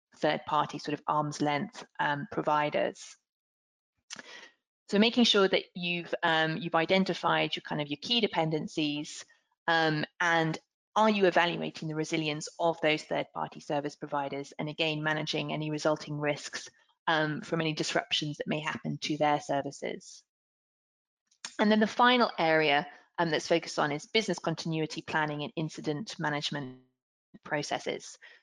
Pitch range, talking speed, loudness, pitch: 150-170 Hz, 140 wpm, -30 LUFS, 160 Hz